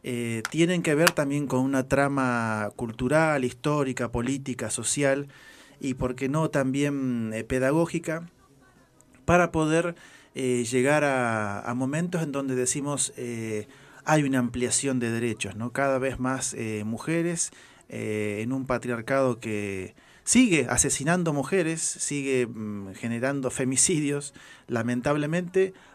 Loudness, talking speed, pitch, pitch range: -26 LUFS, 125 wpm, 130 Hz, 120-150 Hz